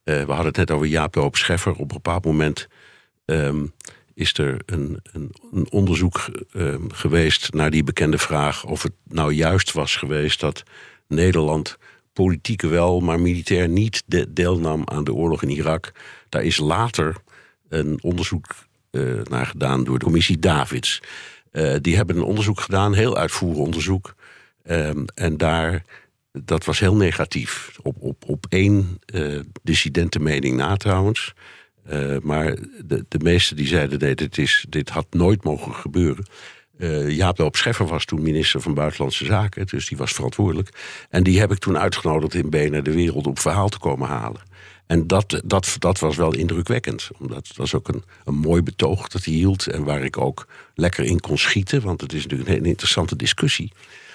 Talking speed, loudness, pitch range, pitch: 175 wpm, -21 LUFS, 75-95 Hz, 85 Hz